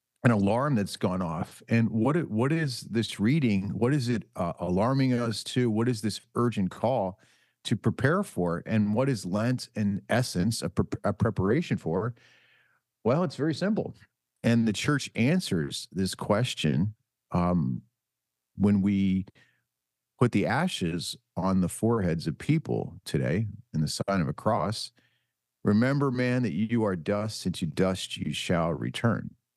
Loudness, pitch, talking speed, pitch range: -28 LUFS, 110 Hz, 155 wpm, 95-125 Hz